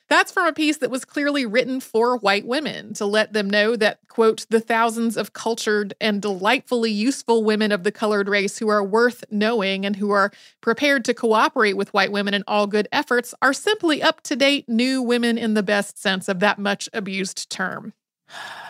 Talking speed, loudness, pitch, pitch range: 200 wpm, -21 LUFS, 220 Hz, 205-250 Hz